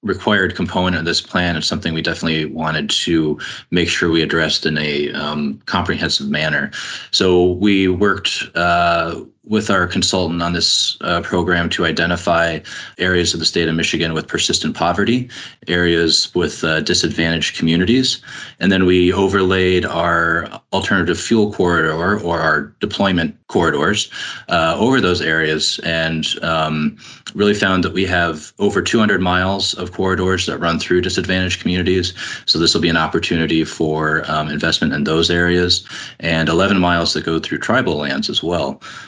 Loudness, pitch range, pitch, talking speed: -16 LUFS, 80-95 Hz, 85 Hz, 155 wpm